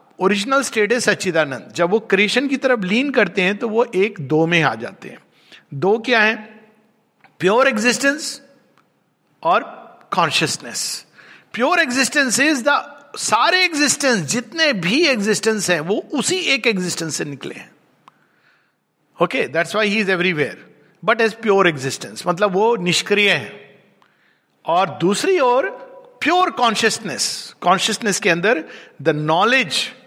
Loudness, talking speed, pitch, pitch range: -17 LUFS, 135 wpm, 220 Hz, 185-265 Hz